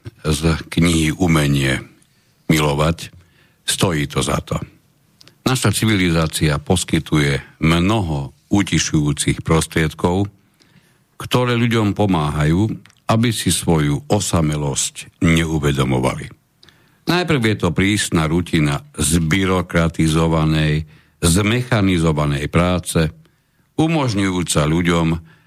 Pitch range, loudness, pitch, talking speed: 80-110 Hz, -18 LUFS, 85 Hz, 75 wpm